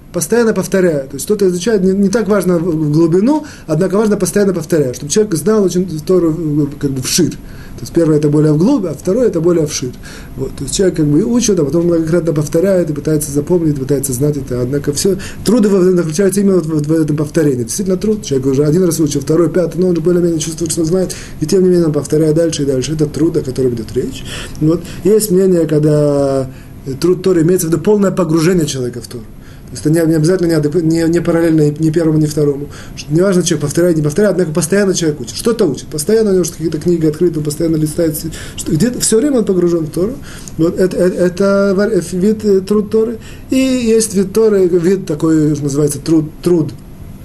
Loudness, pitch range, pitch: -13 LUFS, 150-185 Hz, 165 Hz